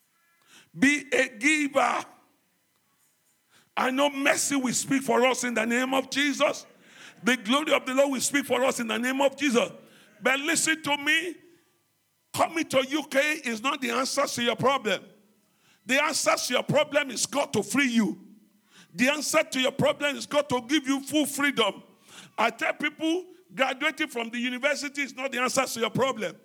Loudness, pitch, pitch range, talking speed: -25 LUFS, 275 Hz, 245-295 Hz, 180 wpm